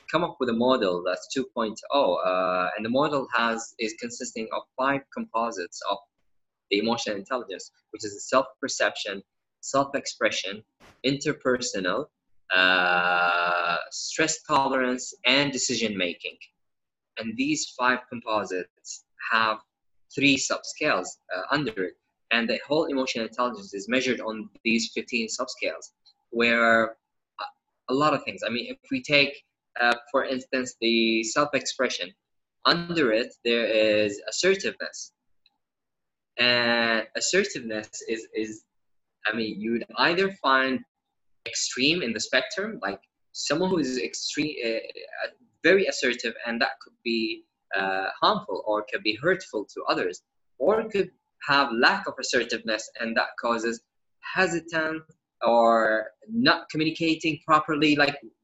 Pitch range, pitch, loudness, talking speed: 110-150 Hz, 125 Hz, -25 LUFS, 125 wpm